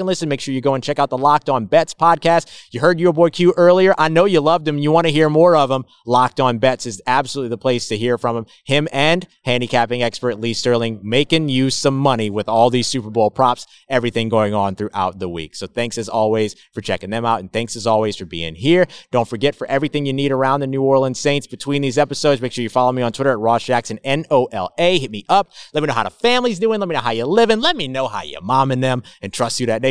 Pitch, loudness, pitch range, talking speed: 130 Hz, -17 LUFS, 115-150 Hz, 275 wpm